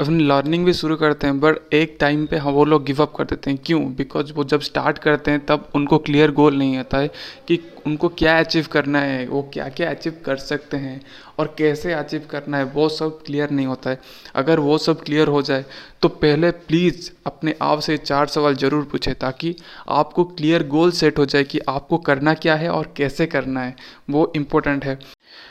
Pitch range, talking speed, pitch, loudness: 140-155 Hz, 215 wpm, 150 Hz, -19 LUFS